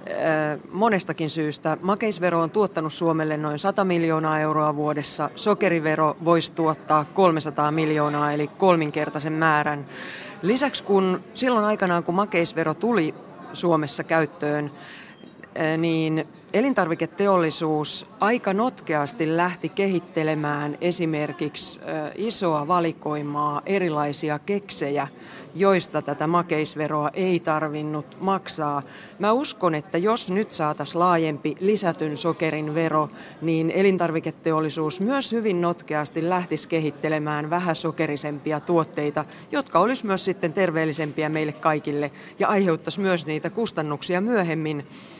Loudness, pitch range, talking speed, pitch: -23 LUFS, 150-180 Hz, 100 wpm, 160 Hz